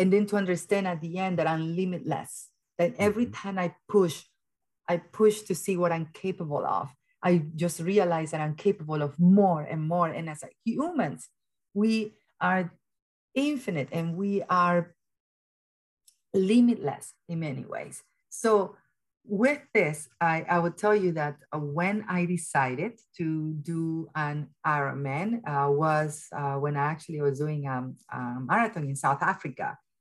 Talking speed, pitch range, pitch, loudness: 150 wpm, 150-195 Hz, 170 Hz, -28 LUFS